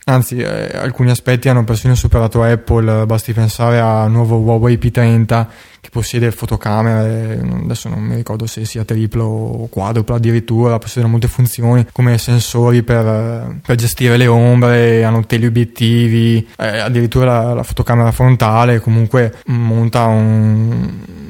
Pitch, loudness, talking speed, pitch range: 115 Hz, -13 LUFS, 135 wpm, 115-120 Hz